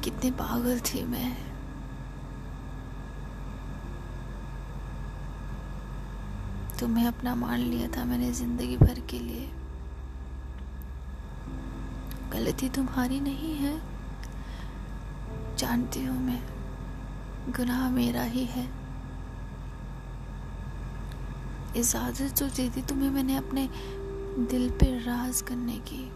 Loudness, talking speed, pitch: -32 LUFS, 85 wpm, 125 Hz